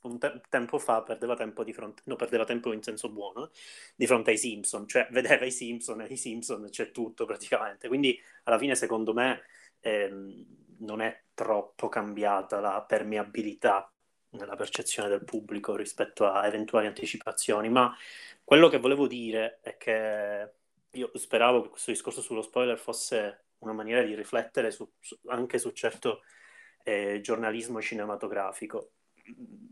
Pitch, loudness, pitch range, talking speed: 110 Hz, -29 LUFS, 105-120 Hz, 155 wpm